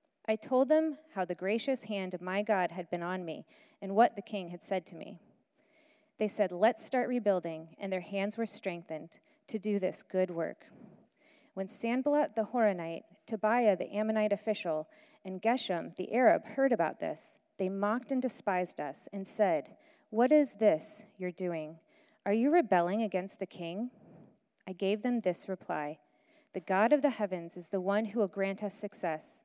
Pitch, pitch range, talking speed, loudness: 205 Hz, 185-235 Hz, 180 wpm, -32 LUFS